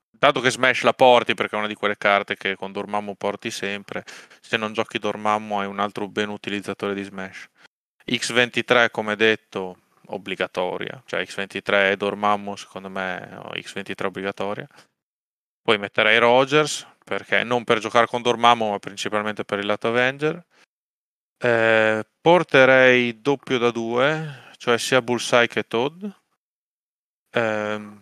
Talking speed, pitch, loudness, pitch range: 140 wpm, 110 Hz, -21 LUFS, 100-120 Hz